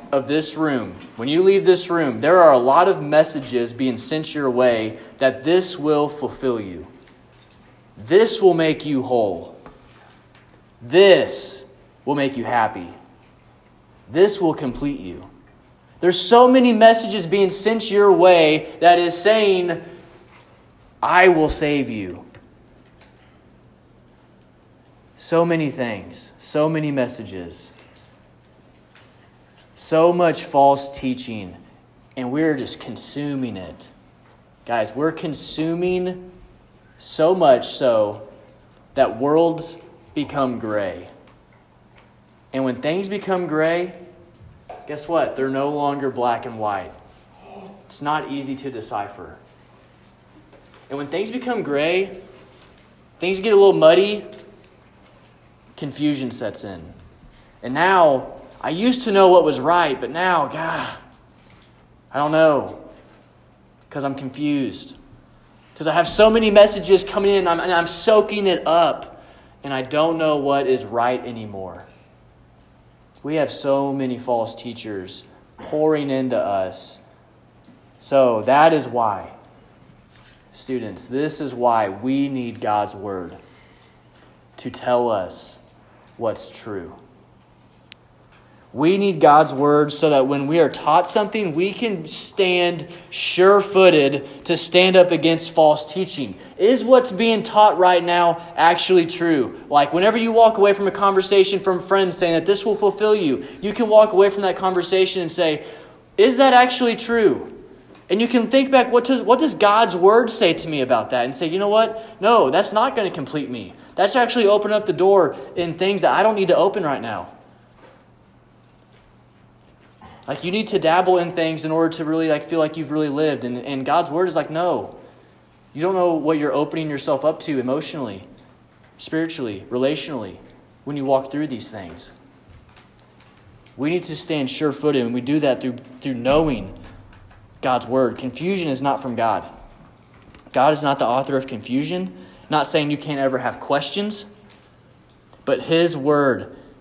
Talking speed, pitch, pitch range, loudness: 145 wpm, 155 Hz, 130-185 Hz, -18 LUFS